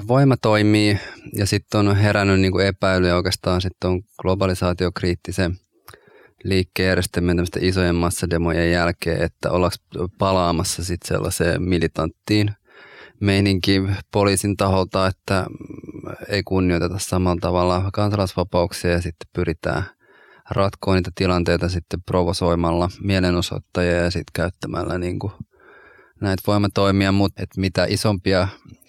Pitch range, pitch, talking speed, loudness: 90-100 Hz, 95 Hz, 105 wpm, -20 LUFS